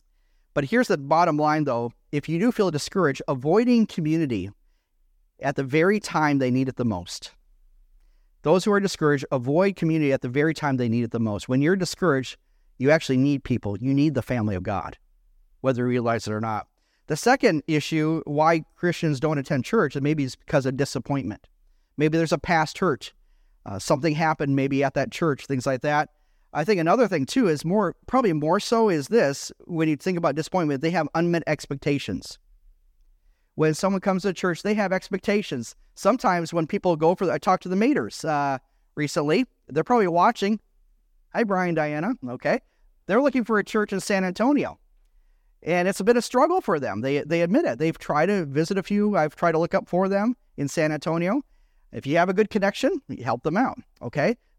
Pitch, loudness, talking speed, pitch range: 155 Hz, -24 LUFS, 200 wpm, 135-190 Hz